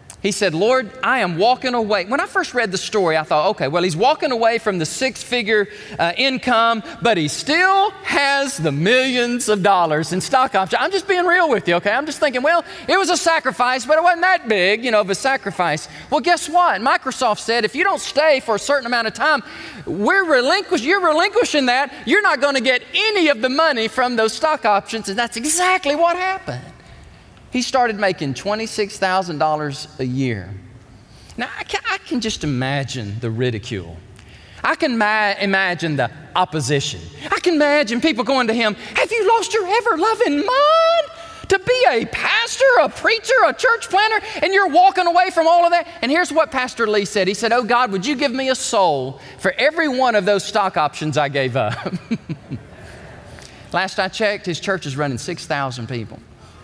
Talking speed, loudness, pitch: 195 wpm, -17 LUFS, 240 Hz